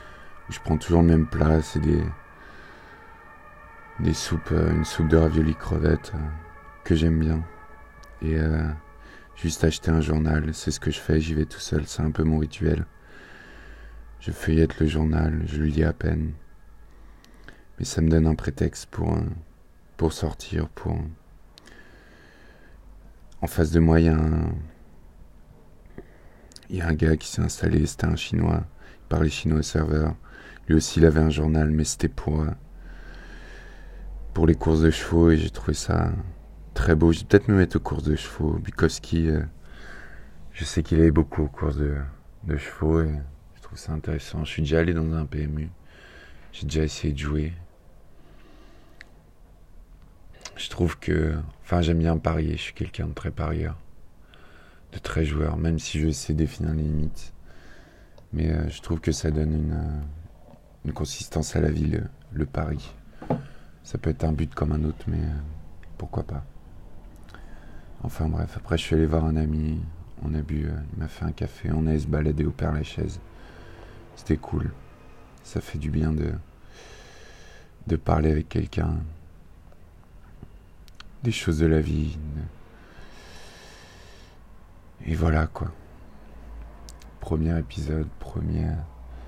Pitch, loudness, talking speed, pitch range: 80 Hz, -25 LUFS, 160 wpm, 75-85 Hz